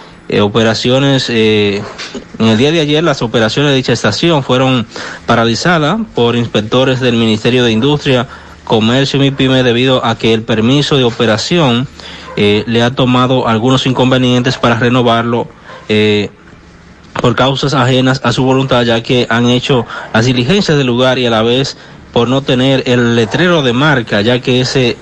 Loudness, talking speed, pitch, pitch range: -11 LUFS, 165 wpm, 125 Hz, 115-135 Hz